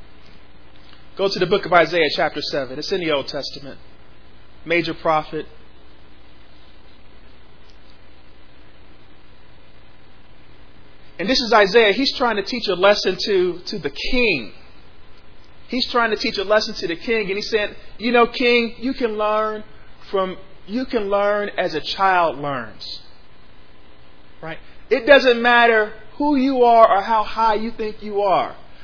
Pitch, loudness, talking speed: 185 Hz, -18 LUFS, 145 wpm